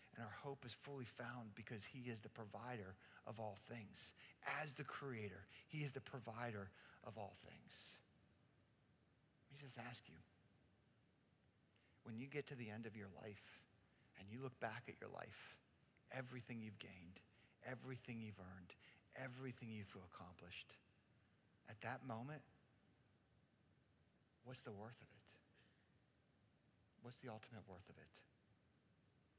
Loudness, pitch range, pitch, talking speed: -54 LUFS, 105-130 Hz, 115 Hz, 140 wpm